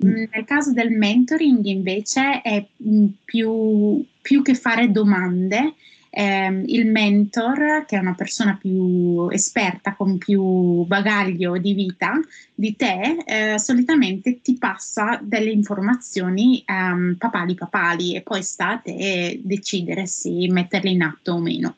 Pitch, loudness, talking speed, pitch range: 205 Hz, -20 LUFS, 130 wpm, 190-235 Hz